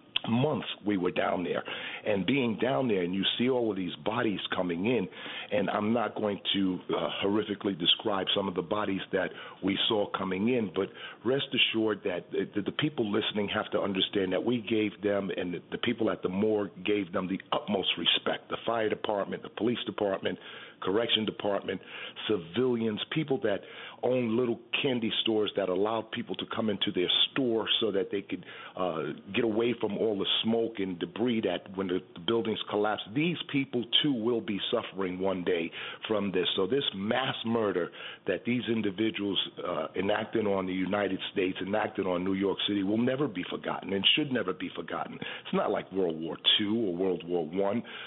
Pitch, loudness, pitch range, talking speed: 105 Hz, -30 LUFS, 95-115 Hz, 185 wpm